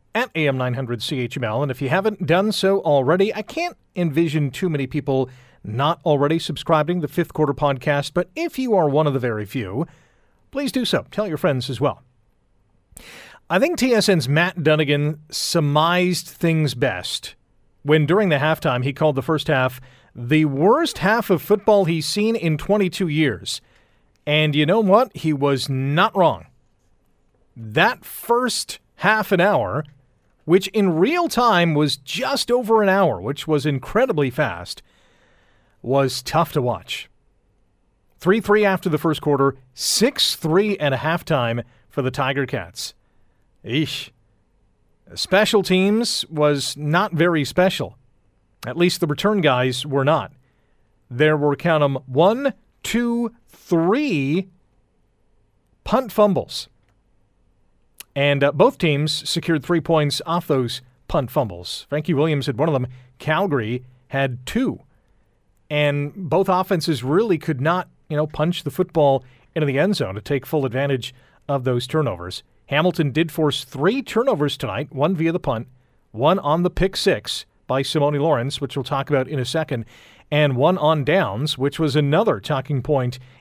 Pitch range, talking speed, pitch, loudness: 130-175 Hz, 155 wpm, 150 Hz, -20 LUFS